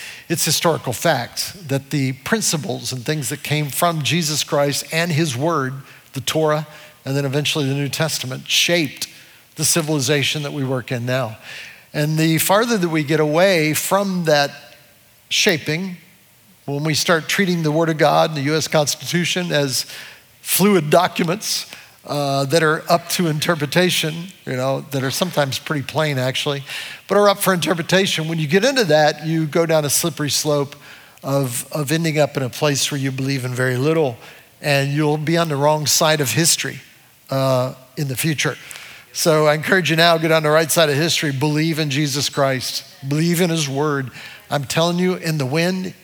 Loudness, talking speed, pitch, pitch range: -18 LUFS, 180 wpm, 150 Hz, 140-165 Hz